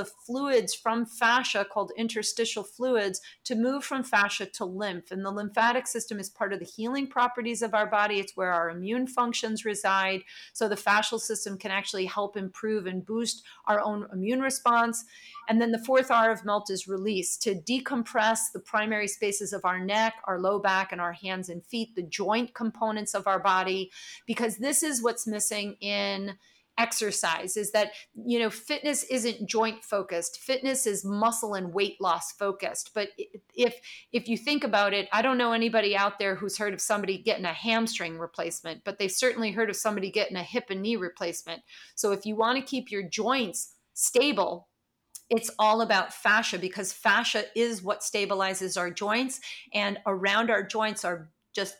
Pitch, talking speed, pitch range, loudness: 210 Hz, 185 wpm, 195-230 Hz, -28 LUFS